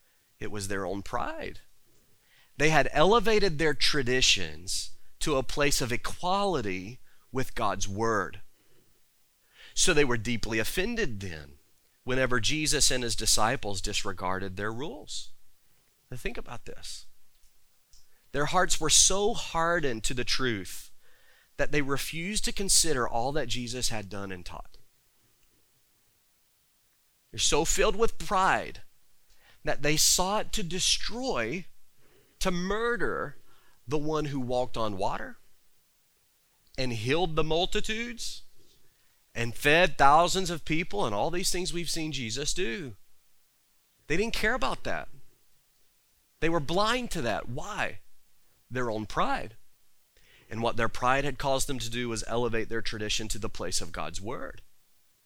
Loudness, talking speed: -28 LUFS, 135 wpm